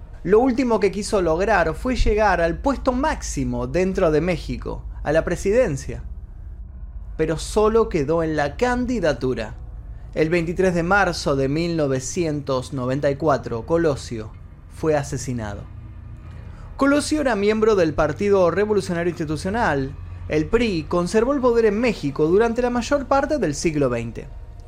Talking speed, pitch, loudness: 125 wpm, 160 Hz, -21 LUFS